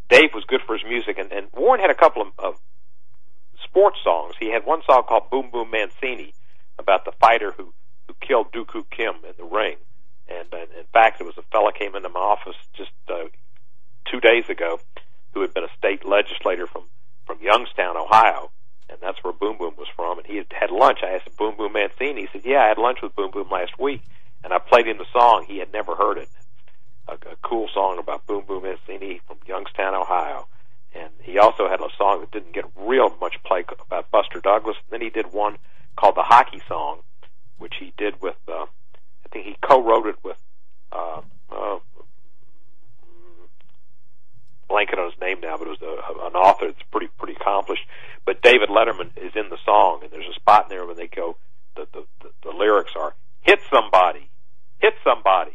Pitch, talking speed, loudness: 370 Hz, 205 wpm, -20 LUFS